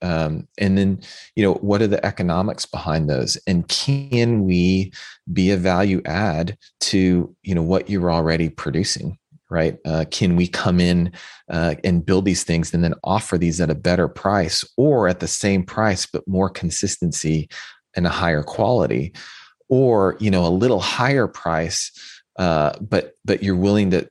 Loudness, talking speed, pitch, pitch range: -20 LUFS, 170 wpm, 90 Hz, 85-95 Hz